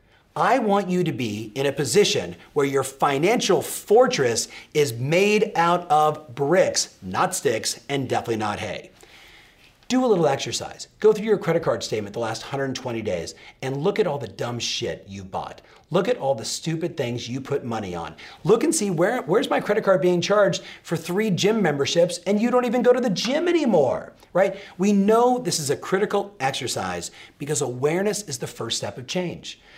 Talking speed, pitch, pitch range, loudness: 190 wpm, 170 Hz, 130-200 Hz, -22 LUFS